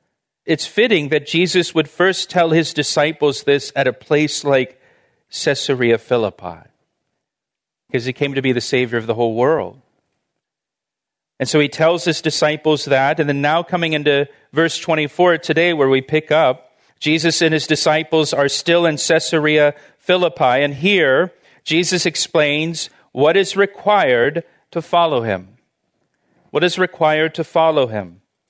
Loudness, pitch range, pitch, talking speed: -16 LUFS, 140-170 Hz, 155 Hz, 150 wpm